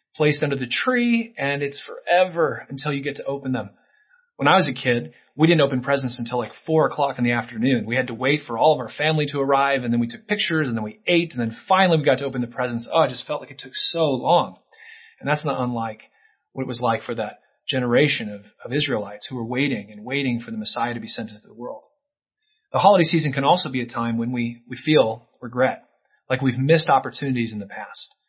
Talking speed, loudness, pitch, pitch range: 245 wpm, -22 LUFS, 135 Hz, 120-155 Hz